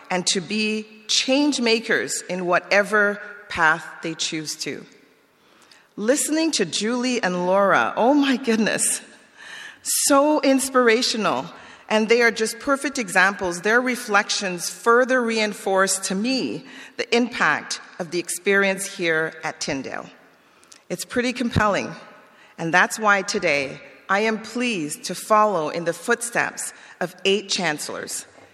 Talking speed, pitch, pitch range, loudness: 125 wpm, 210 Hz, 185-240 Hz, -21 LUFS